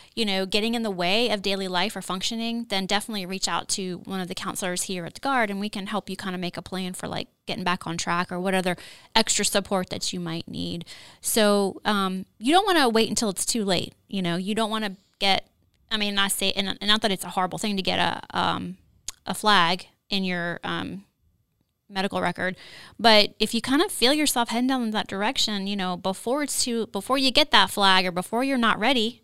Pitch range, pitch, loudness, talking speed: 185-225 Hz, 200 Hz, -24 LUFS, 240 wpm